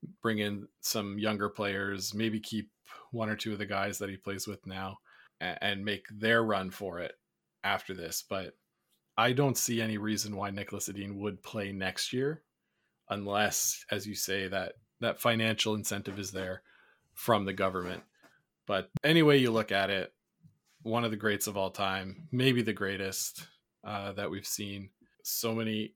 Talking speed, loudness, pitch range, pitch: 170 wpm, -32 LUFS, 100-110 Hz, 105 Hz